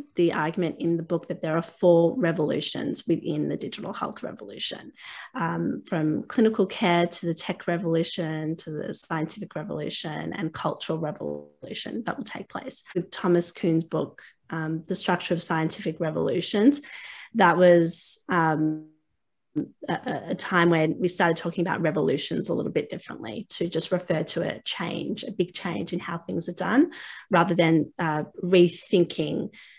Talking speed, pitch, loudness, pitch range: 155 wpm, 175 Hz, -26 LUFS, 160-180 Hz